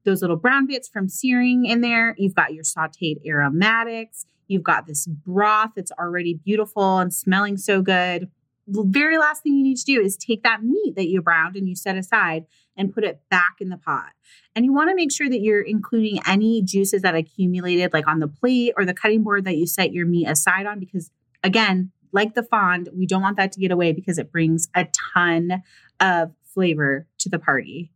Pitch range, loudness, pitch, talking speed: 170-215 Hz, -20 LUFS, 190 Hz, 210 wpm